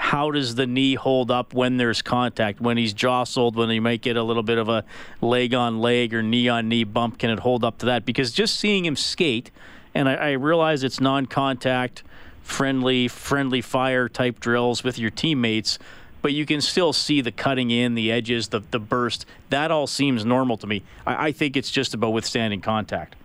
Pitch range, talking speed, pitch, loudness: 115-135 Hz, 210 wpm, 125 Hz, -22 LUFS